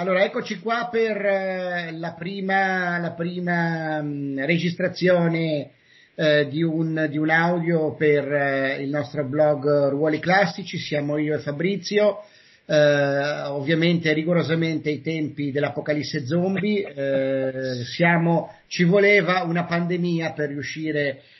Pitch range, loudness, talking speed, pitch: 150-180 Hz, -22 LUFS, 120 wpm, 160 Hz